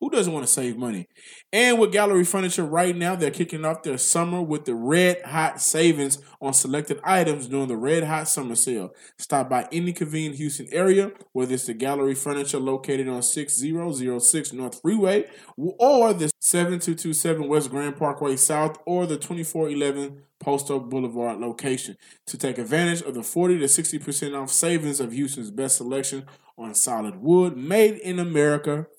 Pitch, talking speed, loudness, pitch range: 150 Hz, 170 wpm, -22 LUFS, 135-175 Hz